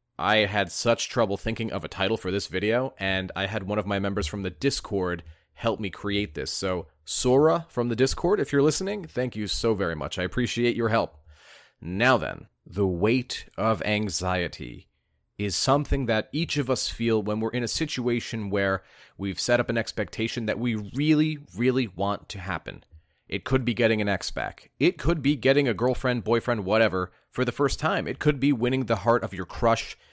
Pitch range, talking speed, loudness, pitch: 95-125 Hz, 200 wpm, -26 LUFS, 110 Hz